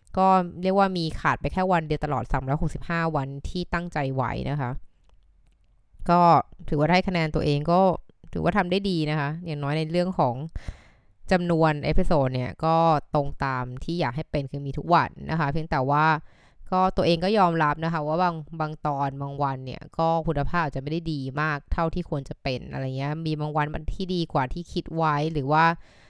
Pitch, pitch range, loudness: 155 Hz, 140-170 Hz, -25 LUFS